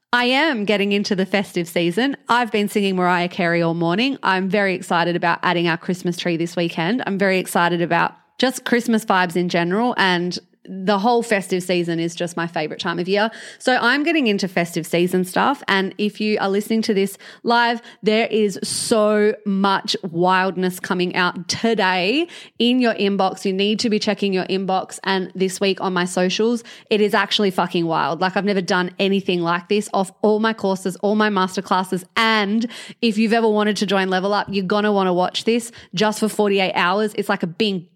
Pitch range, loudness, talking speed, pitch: 180-215 Hz, -19 LUFS, 200 wpm, 195 Hz